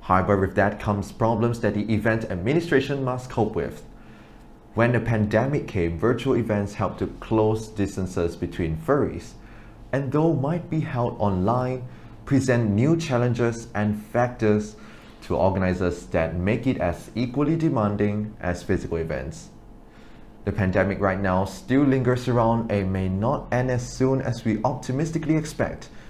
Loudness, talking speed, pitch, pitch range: -24 LUFS, 145 wpm, 110 Hz, 100-125 Hz